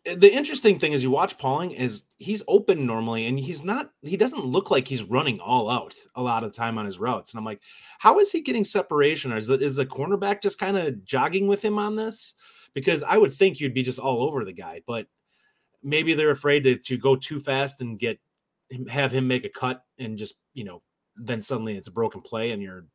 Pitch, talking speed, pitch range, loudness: 135 Hz, 240 wpm, 125-200 Hz, -24 LUFS